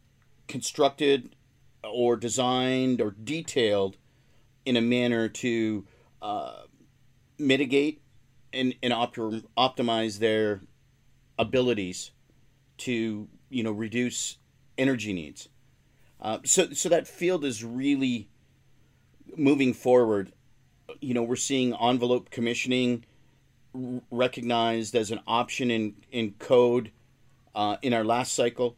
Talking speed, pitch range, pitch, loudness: 105 wpm, 115-130 Hz, 125 Hz, -27 LUFS